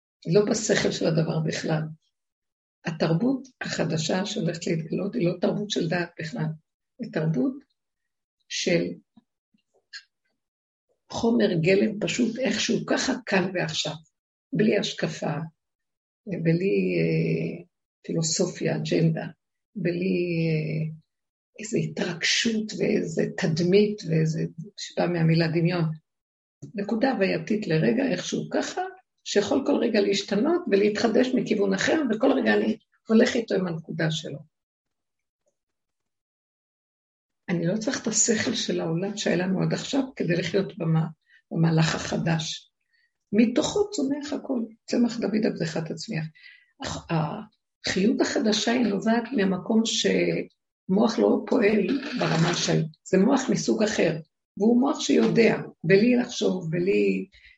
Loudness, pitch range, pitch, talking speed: -25 LUFS, 165-230 Hz, 200 Hz, 110 wpm